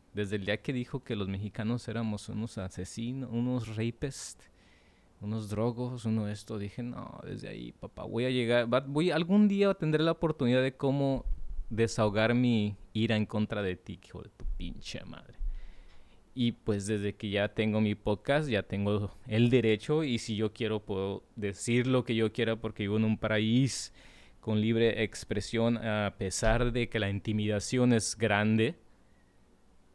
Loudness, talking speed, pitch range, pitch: -31 LUFS, 170 wpm, 105-120 Hz, 110 Hz